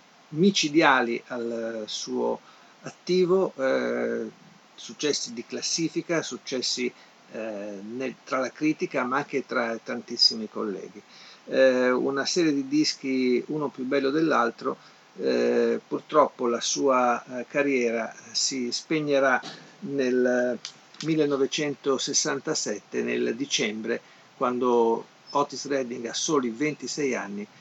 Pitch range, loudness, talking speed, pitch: 120-150 Hz, -26 LUFS, 100 wpm, 130 Hz